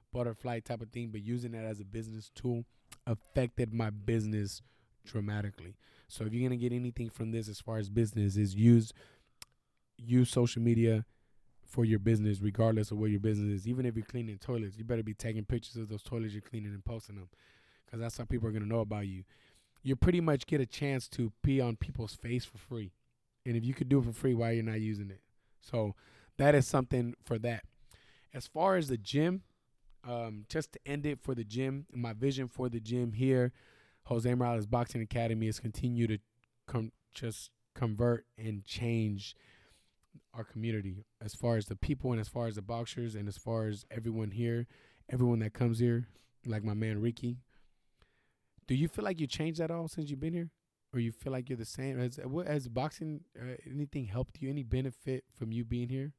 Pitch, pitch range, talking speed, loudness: 120 Hz, 110-125 Hz, 205 wpm, -35 LUFS